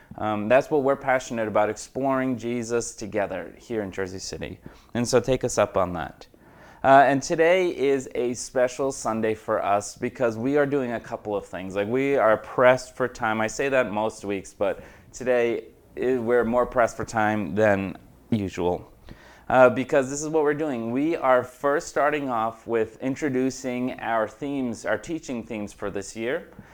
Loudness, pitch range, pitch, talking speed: -24 LUFS, 110-130 Hz, 120 Hz, 180 wpm